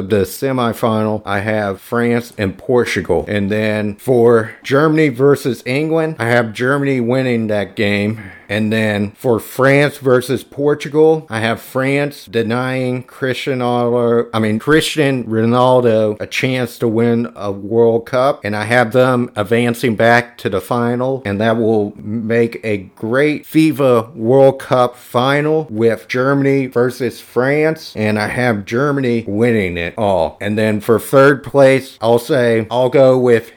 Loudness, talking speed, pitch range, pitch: -15 LUFS, 150 wpm, 110-135 Hz, 120 Hz